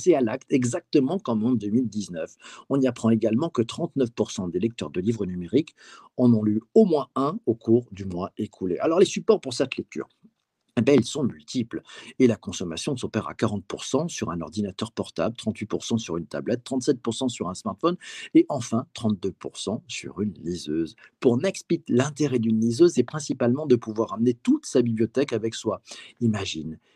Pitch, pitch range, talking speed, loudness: 115 Hz, 105-130 Hz, 175 wpm, -25 LUFS